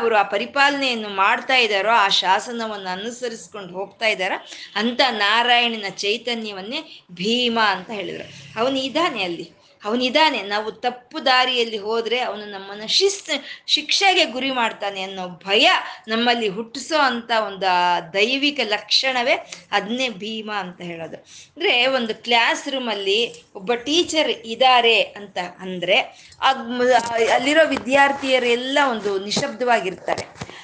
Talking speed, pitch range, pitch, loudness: 110 wpm, 205-265 Hz, 235 Hz, -19 LUFS